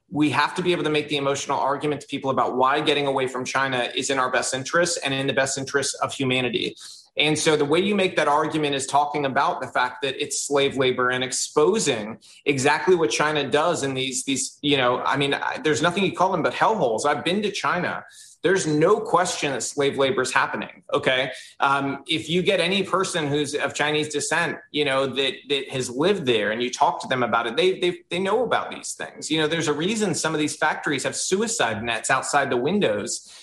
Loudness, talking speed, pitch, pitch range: -22 LUFS, 230 wpm, 140 Hz, 135-155 Hz